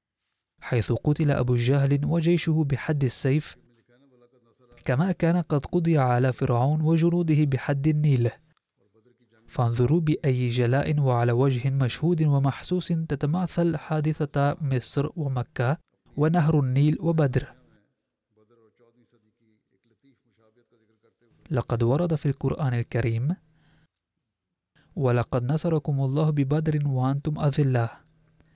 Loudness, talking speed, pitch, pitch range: -25 LUFS, 85 wpm, 135 Hz, 120-155 Hz